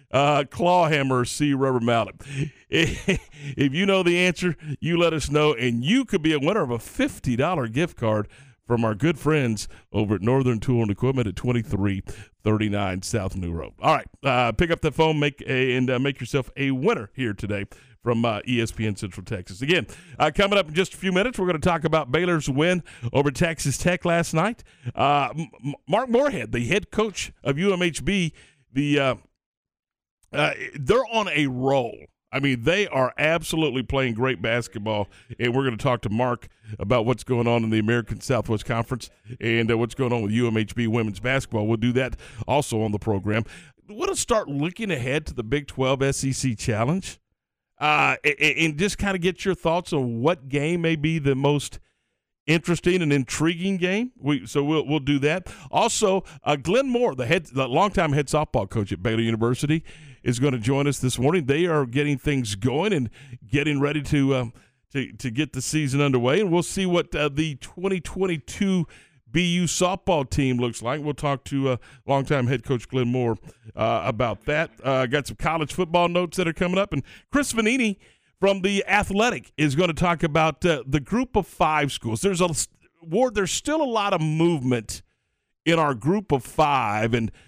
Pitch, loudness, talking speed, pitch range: 140 Hz, -23 LUFS, 195 wpm, 120-170 Hz